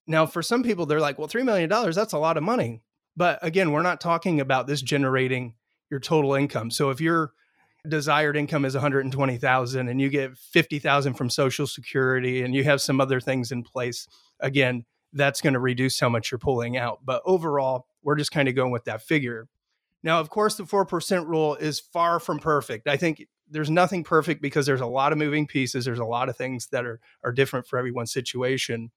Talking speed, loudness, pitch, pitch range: 210 wpm, -24 LUFS, 140 Hz, 130-155 Hz